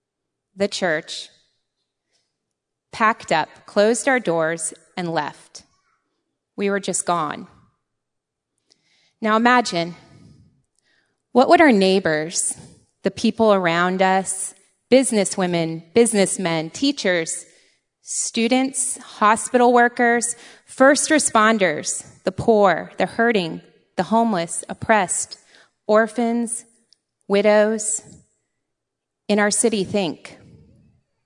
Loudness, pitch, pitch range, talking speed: -19 LUFS, 205 Hz, 180-235 Hz, 85 wpm